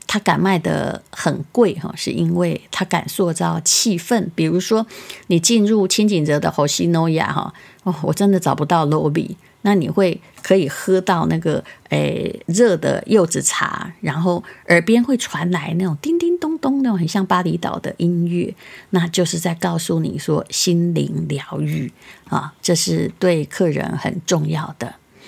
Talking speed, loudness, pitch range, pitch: 235 characters per minute, -18 LUFS, 165-200 Hz, 180 Hz